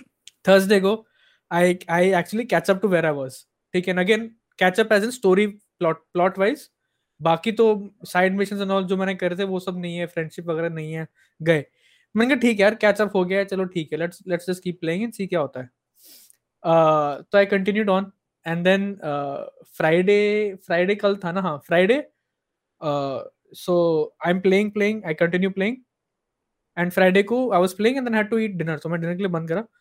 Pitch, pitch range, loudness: 185 Hz, 170-205 Hz, -22 LUFS